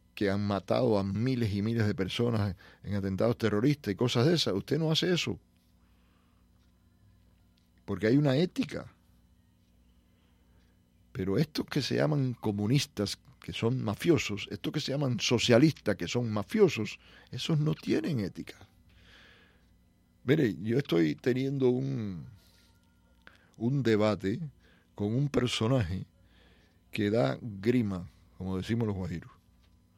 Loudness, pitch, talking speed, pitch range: -30 LUFS, 105 Hz, 125 wpm, 90-125 Hz